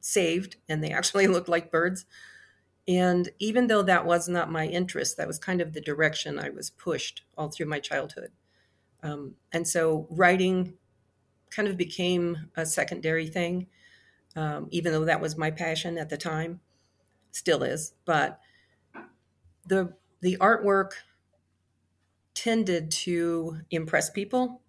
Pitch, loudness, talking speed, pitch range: 170 Hz, -27 LUFS, 140 wpm, 155-185 Hz